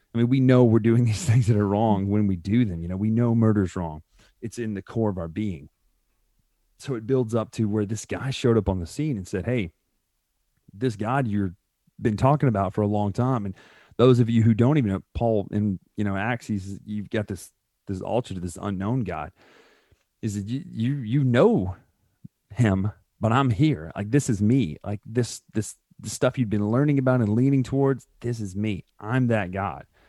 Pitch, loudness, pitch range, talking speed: 110 Hz, -24 LUFS, 100-125 Hz, 215 wpm